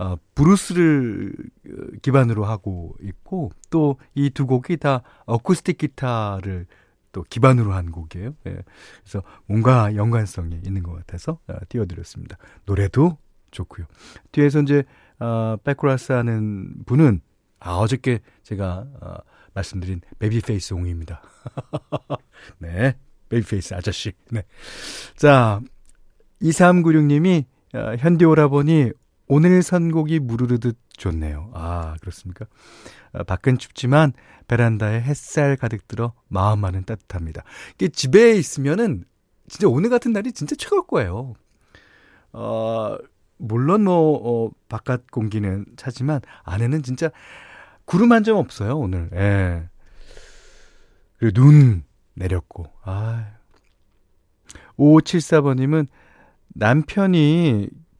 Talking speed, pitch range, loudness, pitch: 240 characters per minute, 95-145 Hz, -20 LUFS, 115 Hz